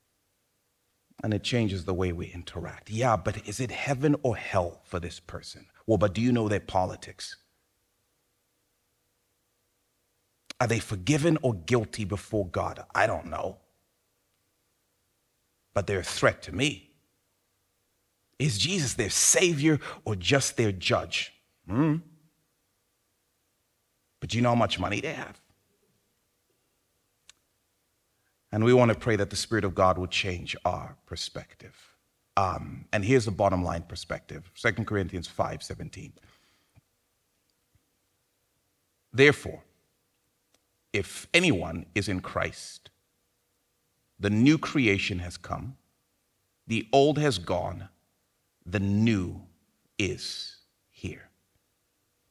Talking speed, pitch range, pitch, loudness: 115 wpm, 95-120 Hz, 100 Hz, -27 LUFS